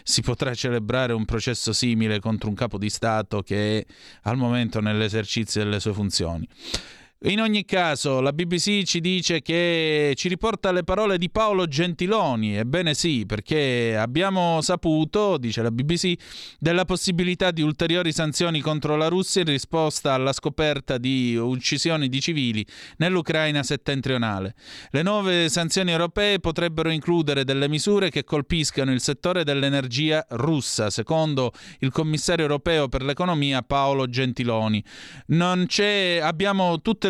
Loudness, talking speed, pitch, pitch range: -23 LUFS, 140 wpm, 150 Hz, 125-175 Hz